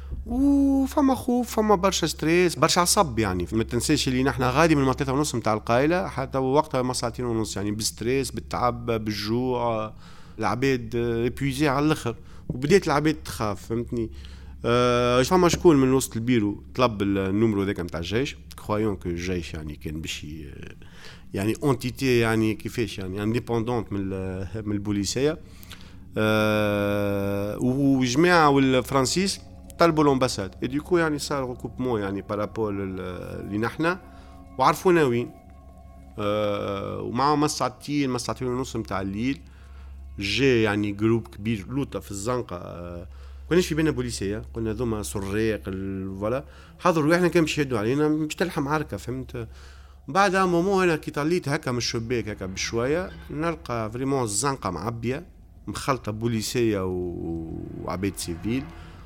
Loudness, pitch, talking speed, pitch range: -24 LUFS, 115 Hz, 135 wpm, 100-135 Hz